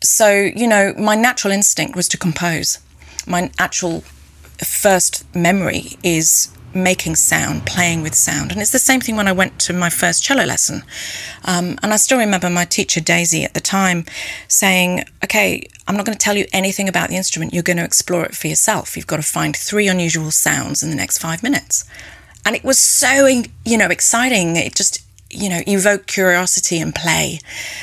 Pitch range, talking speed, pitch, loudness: 165-205 Hz, 190 wpm, 180 Hz, -15 LUFS